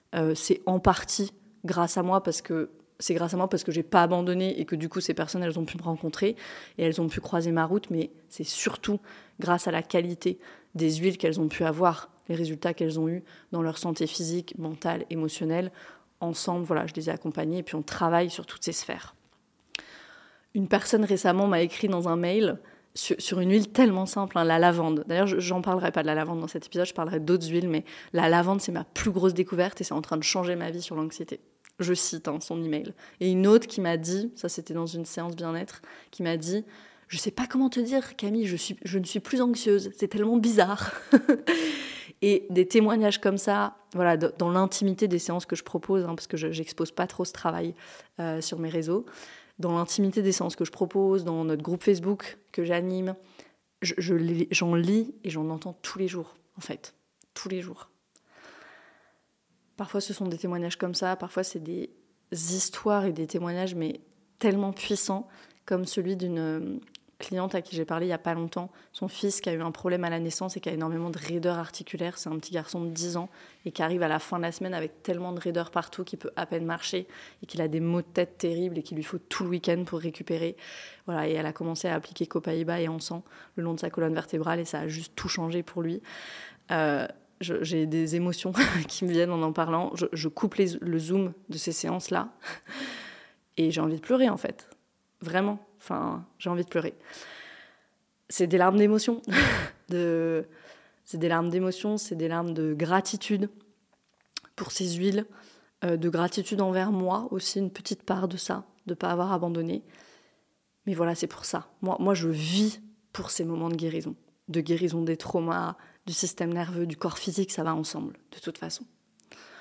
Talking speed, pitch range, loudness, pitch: 215 wpm, 165-195 Hz, -28 LUFS, 175 Hz